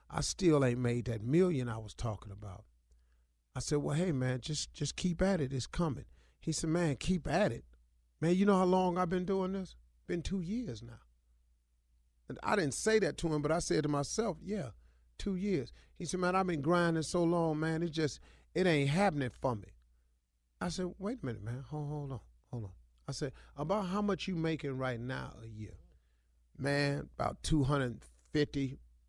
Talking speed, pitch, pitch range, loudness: 205 wpm, 140 Hz, 105-175 Hz, -34 LUFS